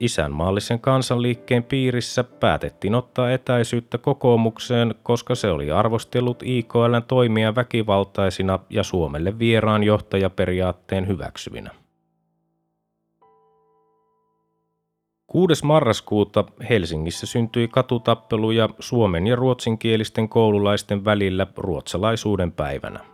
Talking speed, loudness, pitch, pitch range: 80 wpm, -21 LUFS, 110 Hz, 100-120 Hz